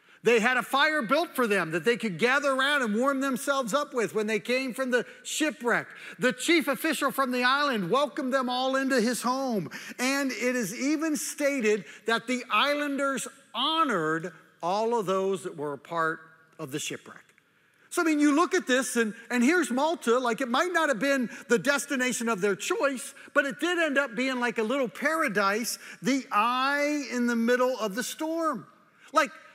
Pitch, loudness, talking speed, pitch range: 255 Hz, -27 LUFS, 195 wpm, 230-285 Hz